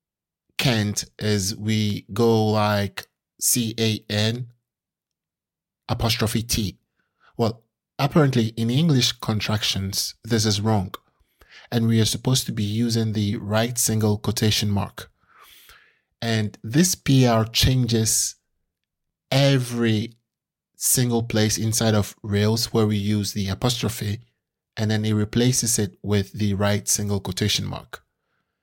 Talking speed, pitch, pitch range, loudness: 115 wpm, 110 Hz, 105-115 Hz, -22 LUFS